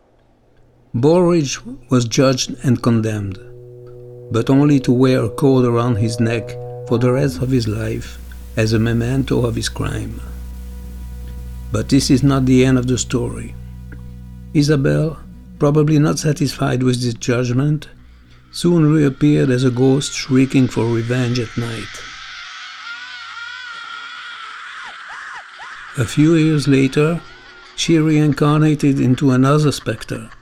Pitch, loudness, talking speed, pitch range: 125 Hz, -16 LUFS, 120 wpm, 115-145 Hz